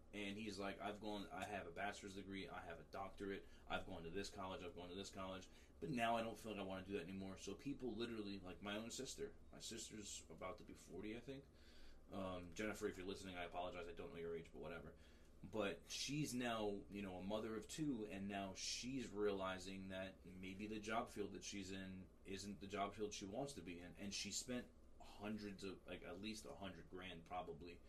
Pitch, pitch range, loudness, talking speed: 100 Hz, 90-105 Hz, -50 LUFS, 230 wpm